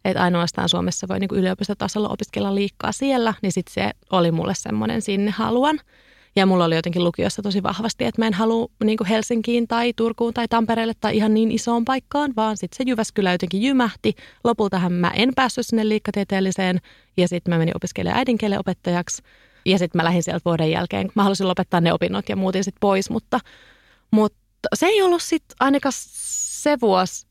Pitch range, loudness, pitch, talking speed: 185-230 Hz, -21 LUFS, 210 Hz, 180 wpm